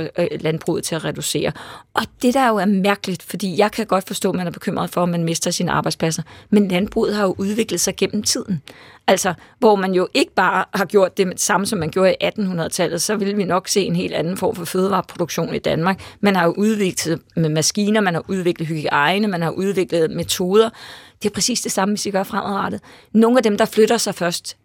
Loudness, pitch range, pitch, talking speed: -19 LUFS, 175-210 Hz, 190 Hz, 220 wpm